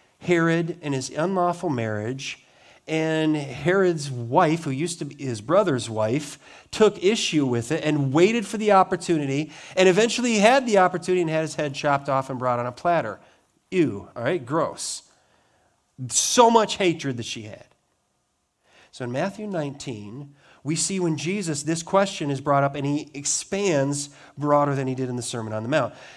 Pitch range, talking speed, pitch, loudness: 135-180 Hz, 175 wpm, 150 Hz, -23 LUFS